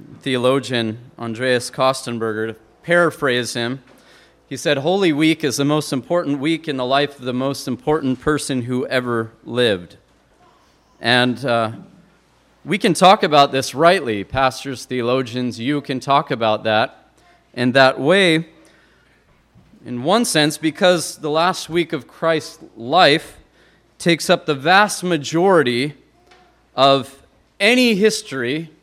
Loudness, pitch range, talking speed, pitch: -18 LUFS, 125-160 Hz, 130 wpm, 140 Hz